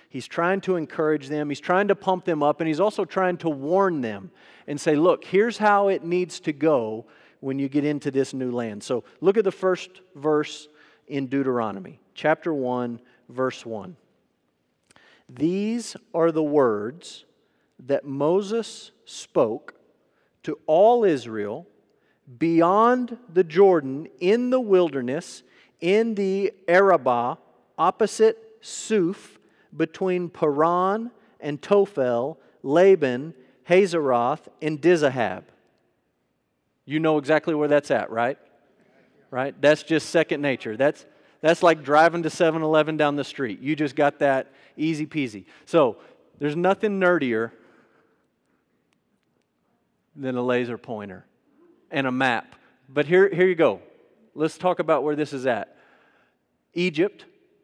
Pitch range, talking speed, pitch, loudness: 140-190 Hz, 130 wpm, 160 Hz, -23 LUFS